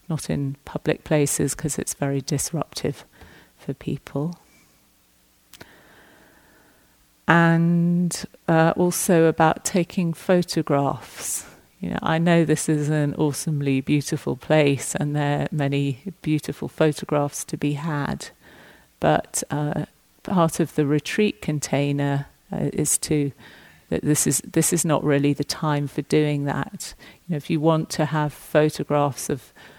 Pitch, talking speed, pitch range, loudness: 150 Hz, 135 wpm, 145-165 Hz, -23 LUFS